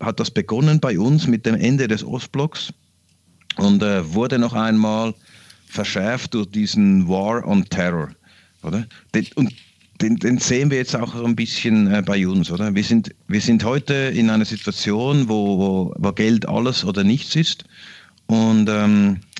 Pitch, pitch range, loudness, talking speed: 115 Hz, 105-140 Hz, -19 LUFS, 165 wpm